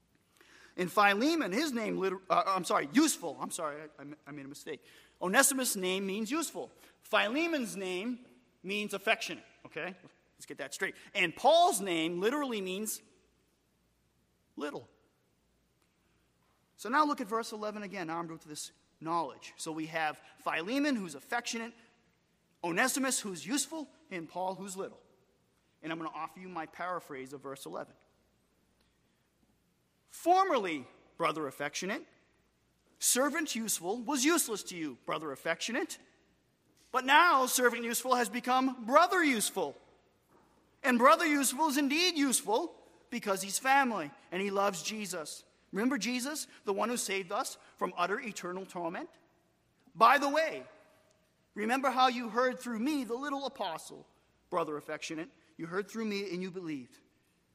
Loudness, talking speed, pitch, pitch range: -32 LUFS, 140 wpm, 220 Hz, 180-275 Hz